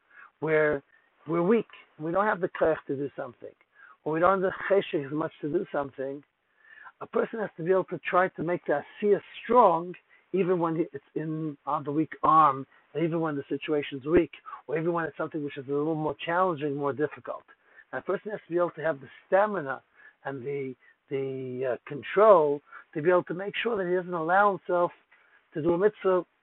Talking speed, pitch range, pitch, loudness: 215 wpm, 145-185 Hz, 165 Hz, -28 LUFS